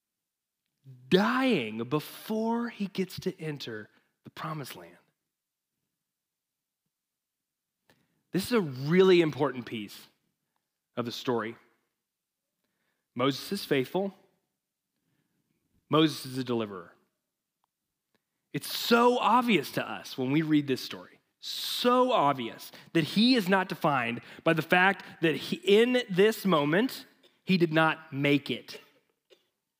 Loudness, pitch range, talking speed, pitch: -27 LUFS, 130-195 Hz, 110 wpm, 165 Hz